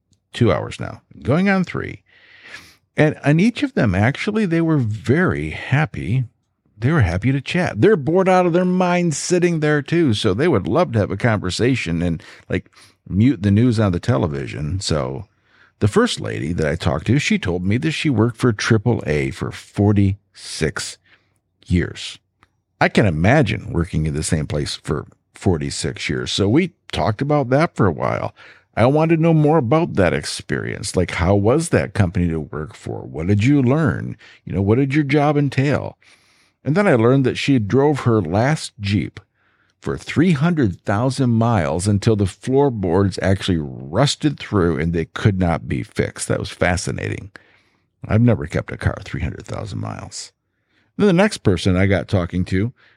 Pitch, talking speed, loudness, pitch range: 115 Hz, 175 wpm, -19 LUFS, 95-150 Hz